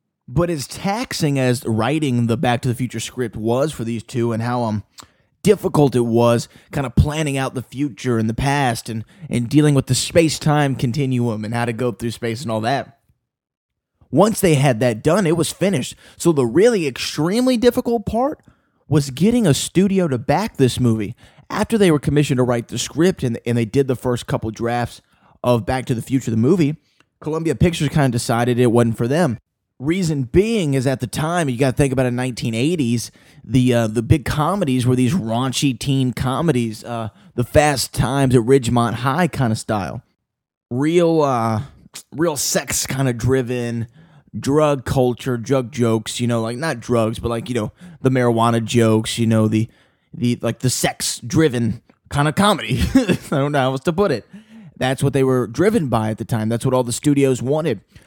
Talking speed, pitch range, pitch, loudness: 195 wpm, 120-150 Hz, 130 Hz, -19 LUFS